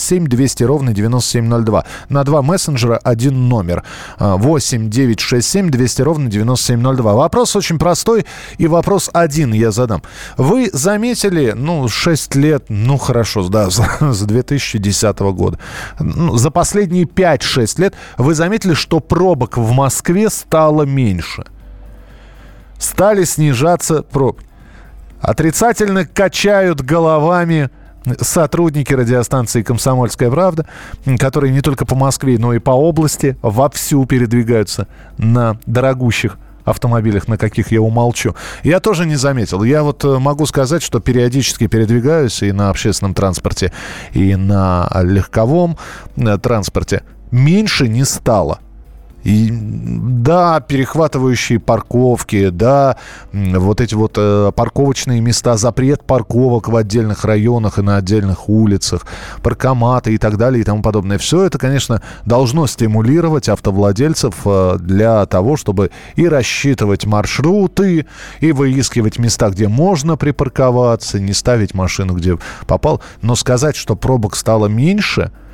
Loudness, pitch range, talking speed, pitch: -14 LUFS, 110-150 Hz, 120 wpm, 125 Hz